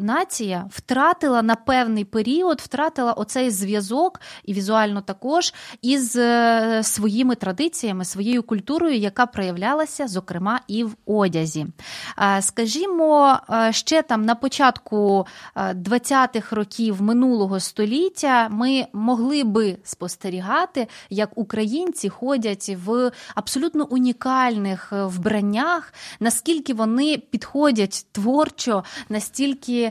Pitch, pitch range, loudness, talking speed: 230 Hz, 210-265 Hz, -21 LUFS, 95 wpm